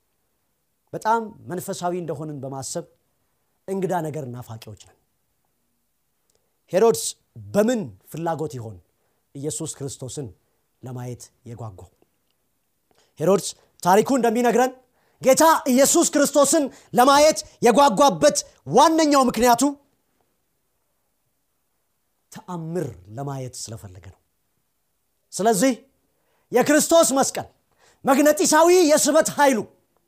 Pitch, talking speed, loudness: 200 Hz, 70 wpm, -19 LUFS